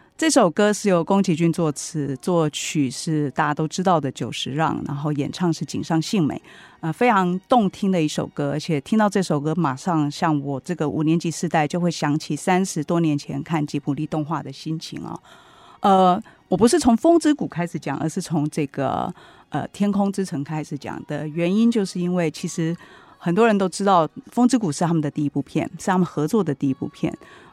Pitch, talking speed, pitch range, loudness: 165 Hz, 305 characters per minute, 150-190 Hz, -22 LUFS